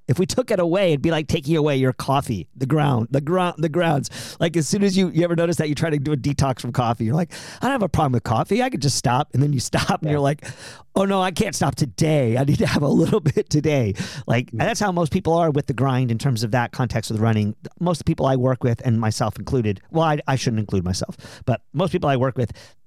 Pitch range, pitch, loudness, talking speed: 125-165 Hz, 140 Hz, -21 LUFS, 280 wpm